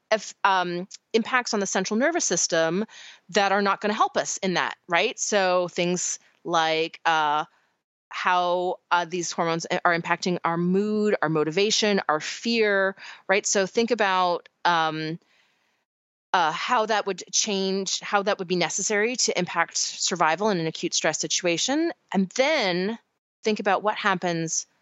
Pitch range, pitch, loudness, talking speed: 170-210 Hz, 190 Hz, -24 LUFS, 150 wpm